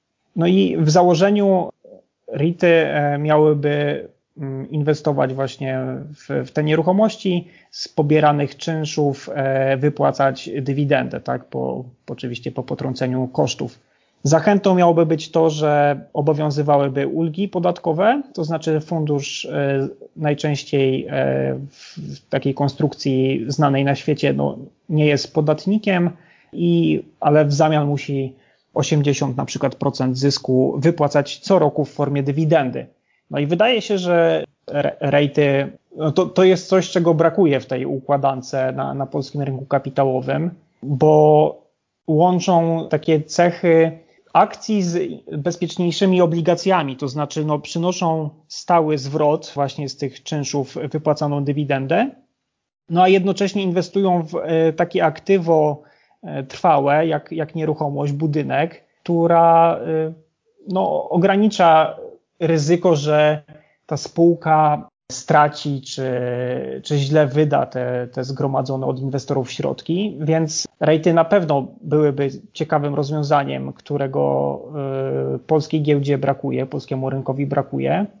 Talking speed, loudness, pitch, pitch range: 115 wpm, -19 LUFS, 150 Hz, 140-165 Hz